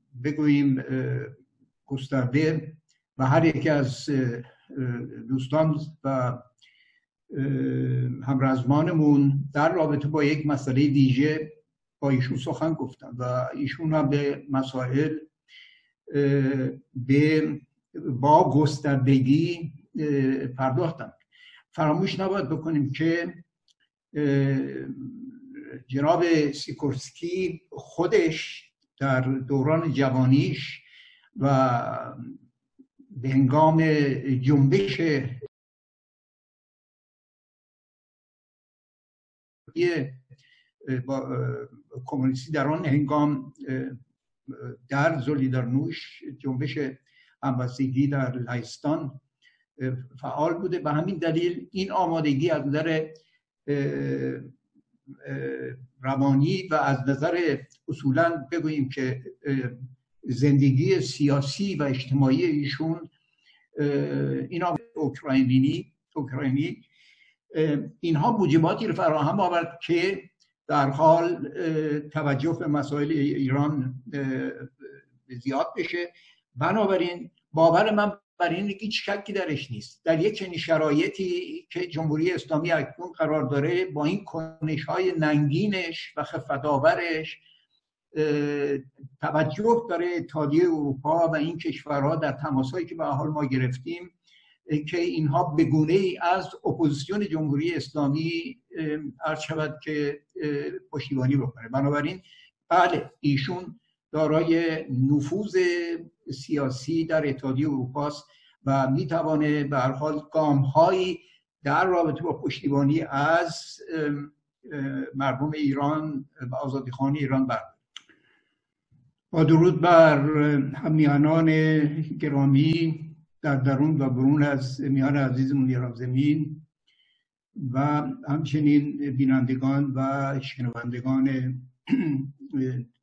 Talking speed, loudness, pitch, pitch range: 85 wpm, -25 LUFS, 145 Hz, 135-160 Hz